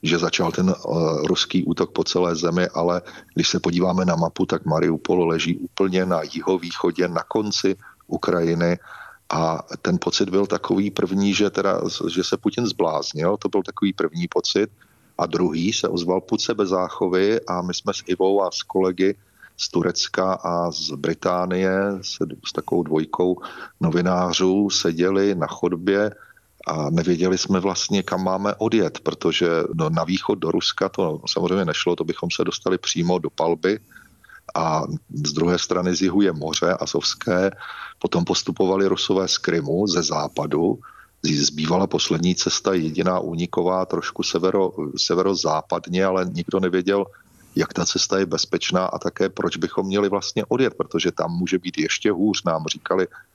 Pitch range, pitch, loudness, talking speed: 85-95 Hz, 90 Hz, -22 LUFS, 155 wpm